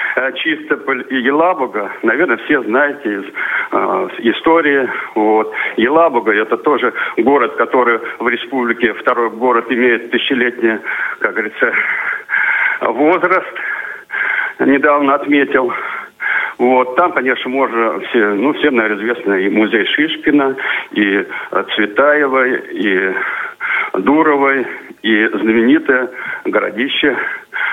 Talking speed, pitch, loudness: 95 wpm, 155 Hz, -14 LUFS